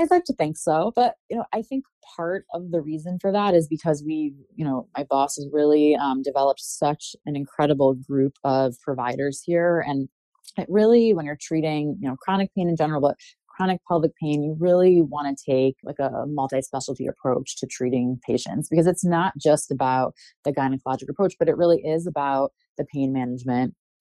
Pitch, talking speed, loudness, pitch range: 150 Hz, 195 wpm, -23 LUFS, 135-175 Hz